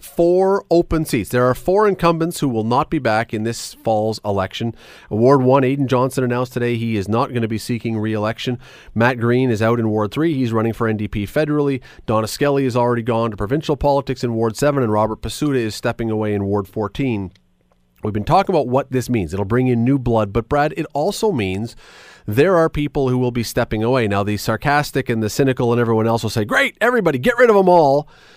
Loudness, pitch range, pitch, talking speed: -18 LUFS, 110-145 Hz, 120 Hz, 220 wpm